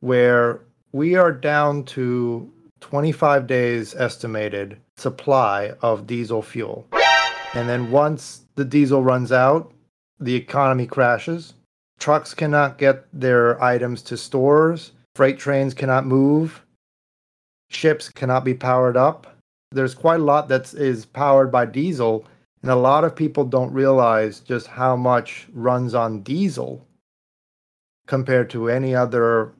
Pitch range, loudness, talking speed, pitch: 120-140 Hz, -19 LUFS, 130 wpm, 130 Hz